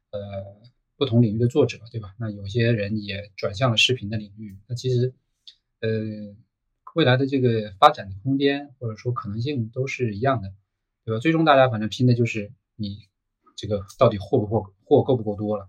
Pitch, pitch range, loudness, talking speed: 110 Hz, 105-125 Hz, -23 LUFS, 285 characters per minute